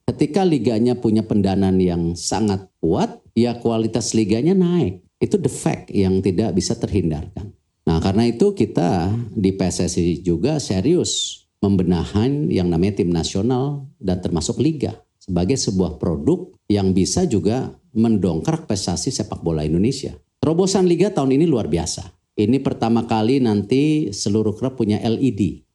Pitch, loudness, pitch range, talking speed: 110 Hz, -20 LUFS, 95-125 Hz, 135 wpm